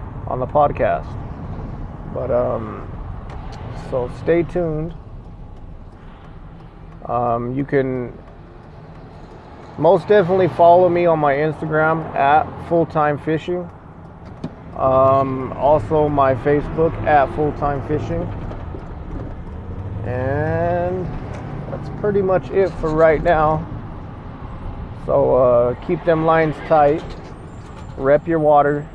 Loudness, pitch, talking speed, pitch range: -18 LUFS, 145 Hz, 95 wpm, 120-160 Hz